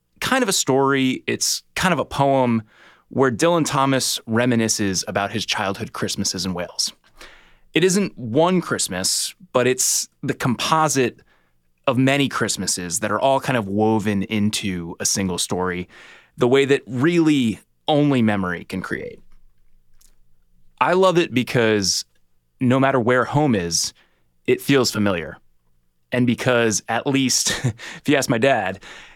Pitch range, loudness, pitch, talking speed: 90-135 Hz, -20 LUFS, 115 Hz, 140 wpm